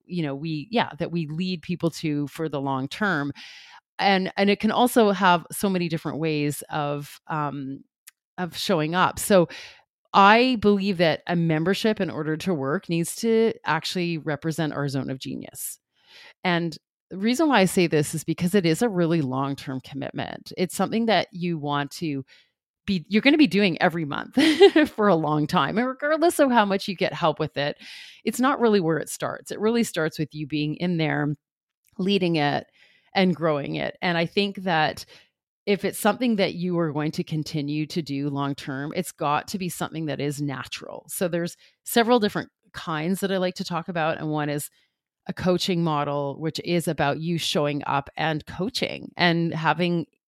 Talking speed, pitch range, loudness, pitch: 190 wpm, 150-195 Hz, -24 LUFS, 170 Hz